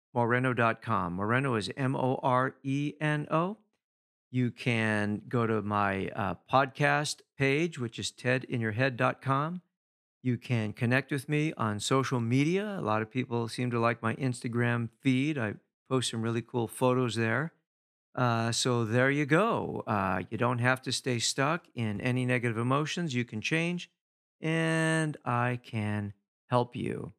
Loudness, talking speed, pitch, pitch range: -30 LUFS, 150 wpm, 125 Hz, 115-140 Hz